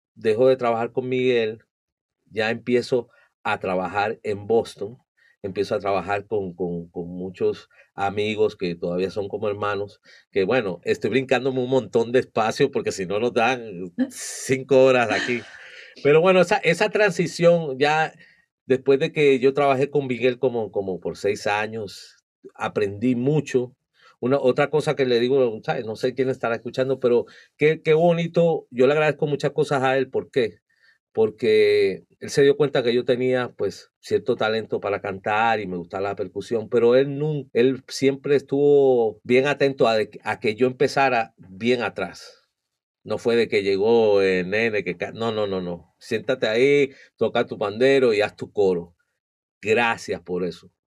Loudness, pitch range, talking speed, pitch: -22 LUFS, 110-145 Hz, 165 wpm, 130 Hz